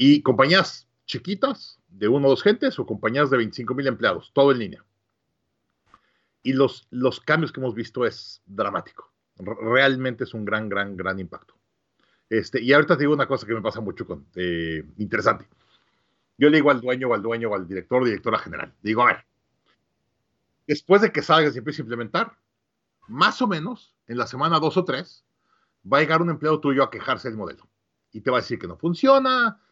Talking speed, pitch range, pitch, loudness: 205 wpm, 110-155 Hz, 130 Hz, -22 LUFS